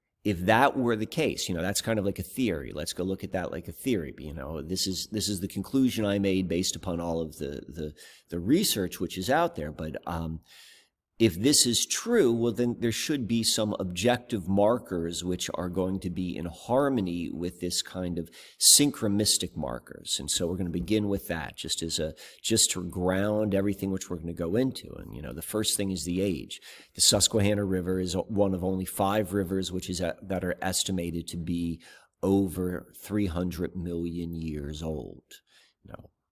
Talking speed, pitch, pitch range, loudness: 205 wpm, 95 Hz, 85-105 Hz, -28 LUFS